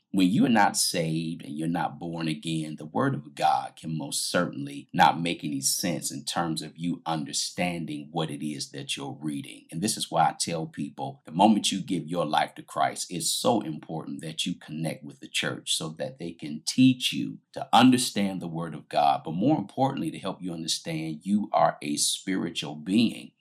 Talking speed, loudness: 205 wpm, -27 LUFS